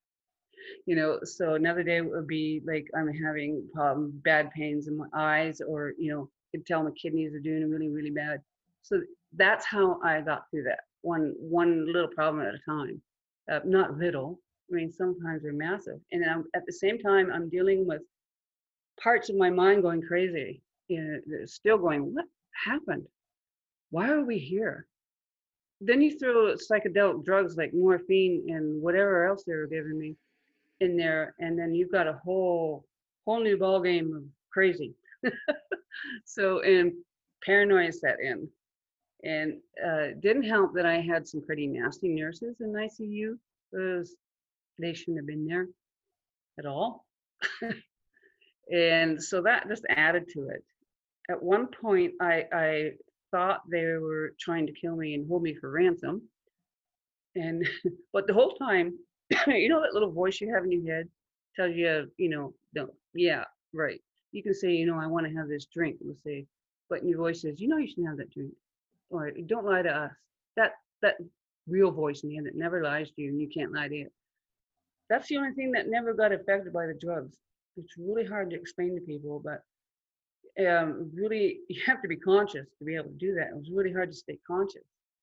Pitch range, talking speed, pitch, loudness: 155-205 Hz, 185 wpm, 175 Hz, -29 LUFS